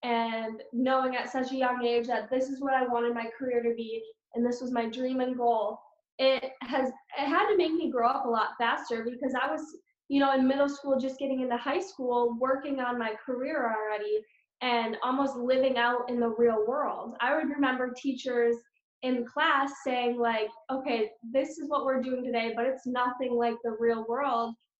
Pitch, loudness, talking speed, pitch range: 250 Hz, -29 LUFS, 205 wpm, 235-270 Hz